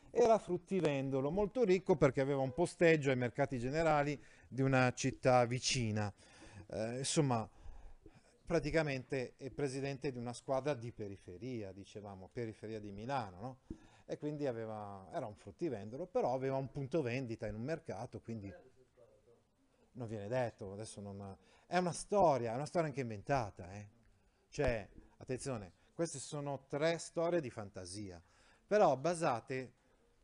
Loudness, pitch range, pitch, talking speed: -37 LUFS, 110-145 Hz, 130 Hz, 140 wpm